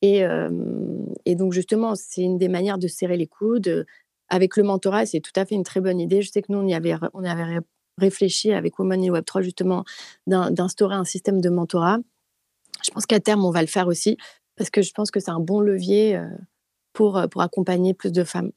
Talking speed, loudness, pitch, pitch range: 225 wpm, -22 LUFS, 190 Hz, 180-205 Hz